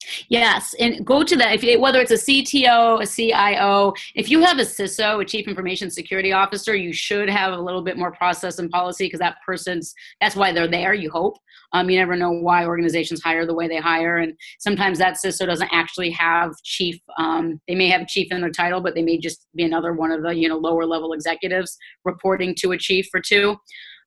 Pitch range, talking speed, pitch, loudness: 170-200 Hz, 220 wpm, 185 Hz, -19 LUFS